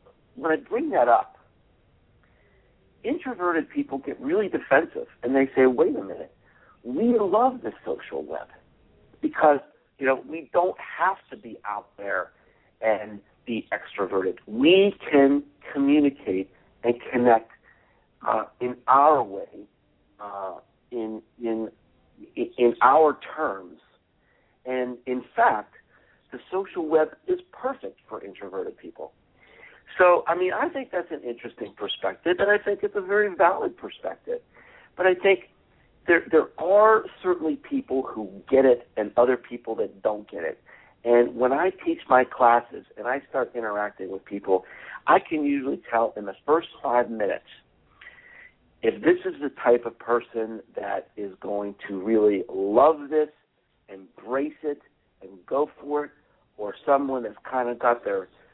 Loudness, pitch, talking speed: -24 LUFS, 140 Hz, 145 wpm